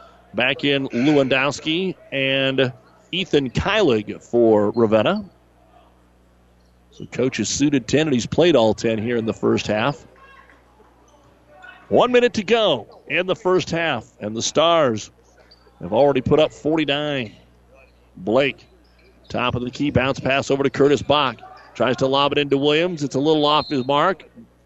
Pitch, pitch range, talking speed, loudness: 135 Hz, 110-150 Hz, 150 wpm, -19 LUFS